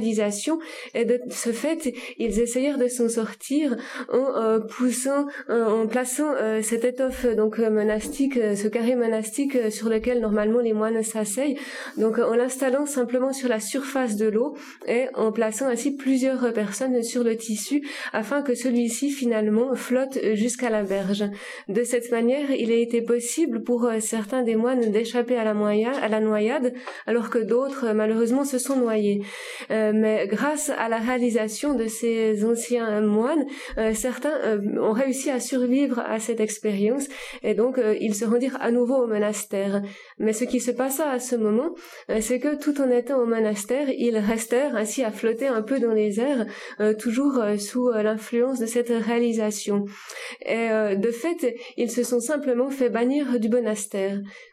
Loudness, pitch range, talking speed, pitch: -24 LUFS, 220-260 Hz, 175 wpm, 235 Hz